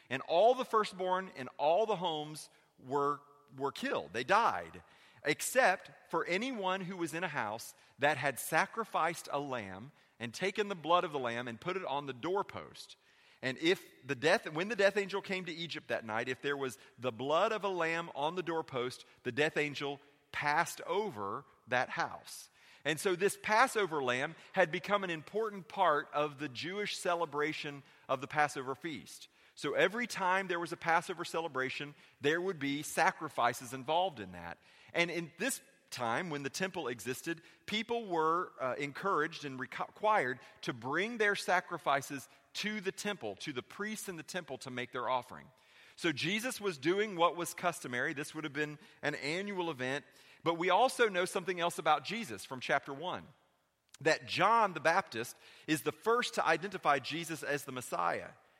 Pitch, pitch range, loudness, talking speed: 165 Hz, 145-190 Hz, -35 LUFS, 175 wpm